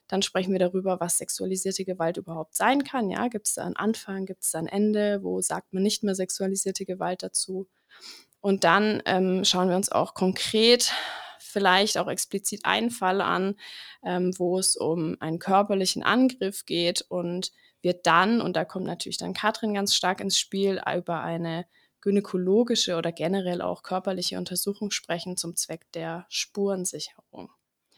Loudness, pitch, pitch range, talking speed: -26 LUFS, 190 Hz, 180-200 Hz, 165 wpm